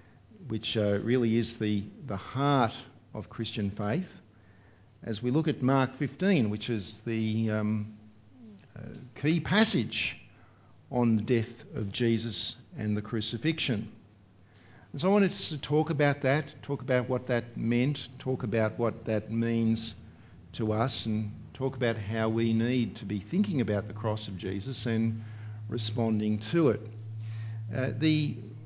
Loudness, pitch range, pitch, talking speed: -30 LUFS, 110-130 Hz, 115 Hz, 150 wpm